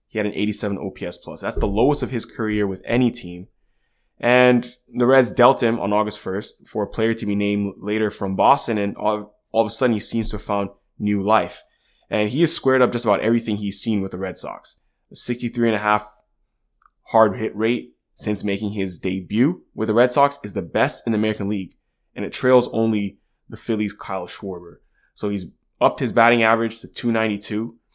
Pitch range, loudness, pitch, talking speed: 100-115 Hz, -21 LUFS, 110 Hz, 210 wpm